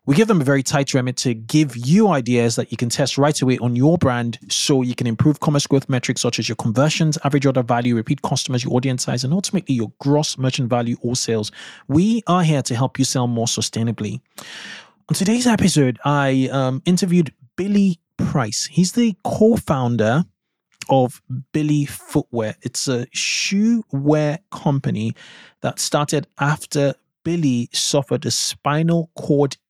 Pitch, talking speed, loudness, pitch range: 140 Hz, 170 wpm, -19 LUFS, 125-160 Hz